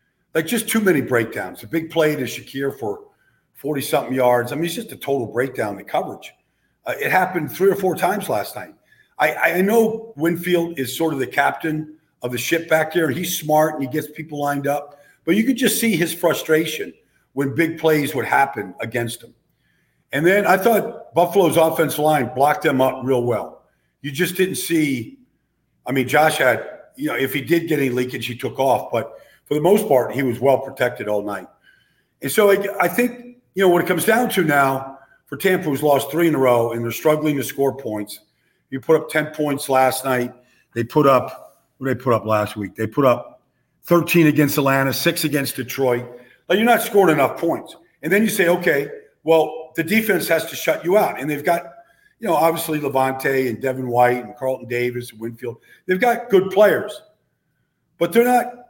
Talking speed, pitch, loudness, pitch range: 210 wpm, 155 Hz, -19 LUFS, 130-175 Hz